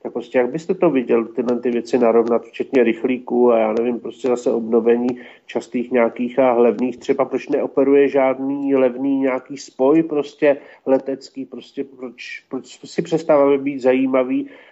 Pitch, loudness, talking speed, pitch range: 130 Hz, -18 LUFS, 155 wpm, 120-140 Hz